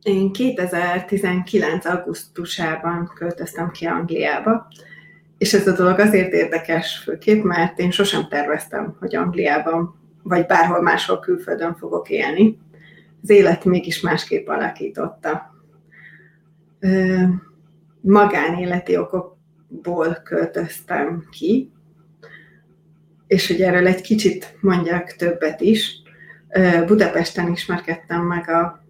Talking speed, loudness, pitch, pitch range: 95 wpm, -19 LUFS, 175 Hz, 165-190 Hz